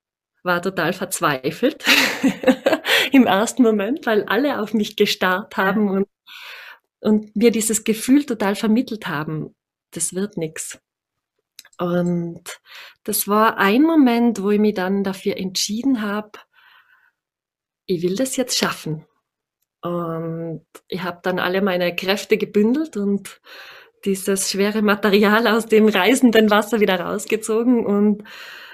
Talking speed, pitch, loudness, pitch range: 125 wpm, 210 Hz, -19 LUFS, 185-235 Hz